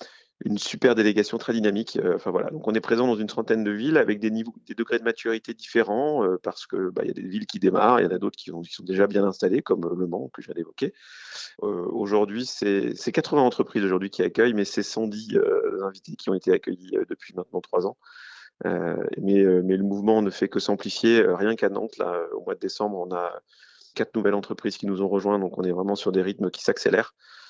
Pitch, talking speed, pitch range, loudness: 105 Hz, 245 wpm, 100-120 Hz, -25 LUFS